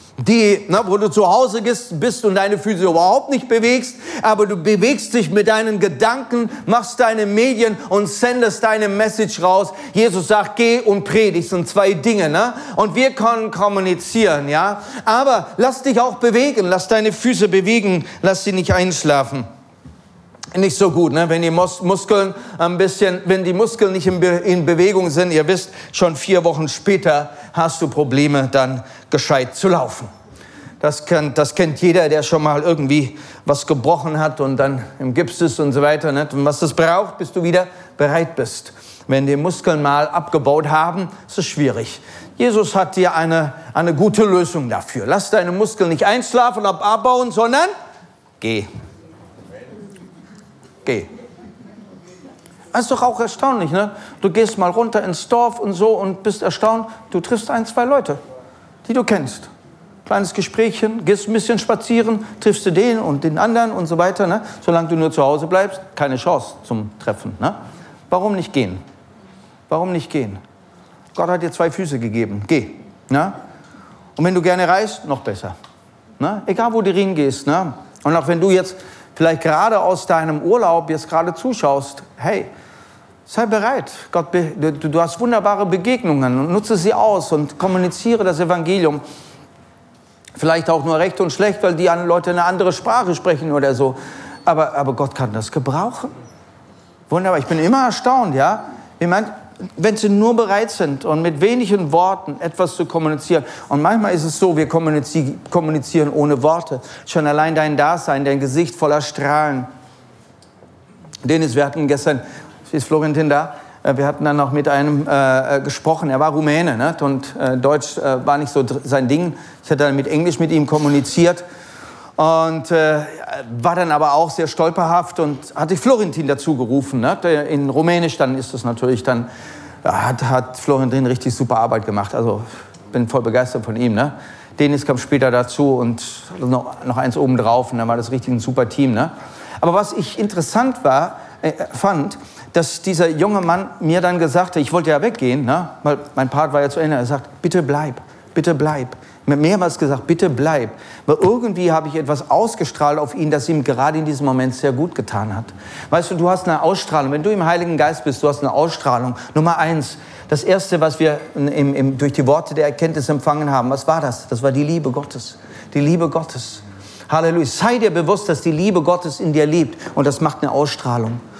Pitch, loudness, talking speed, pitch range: 165 Hz, -17 LUFS, 180 wpm, 145-195 Hz